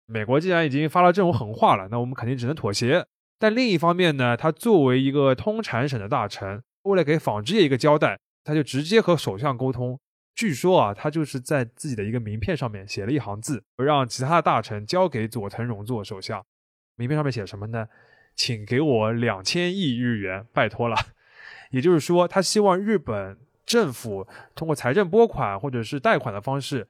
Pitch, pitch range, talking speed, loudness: 130 Hz, 115-160 Hz, 305 characters per minute, -23 LUFS